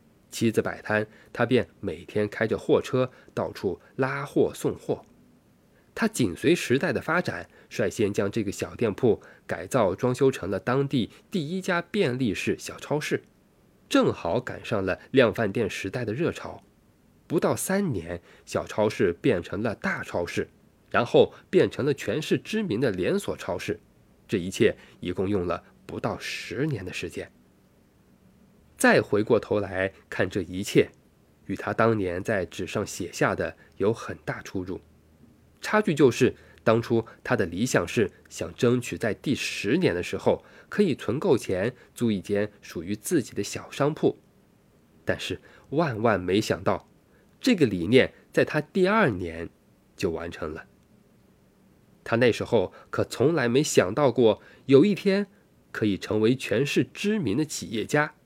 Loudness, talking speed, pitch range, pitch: -26 LUFS, 220 characters per minute, 95-150 Hz, 110 Hz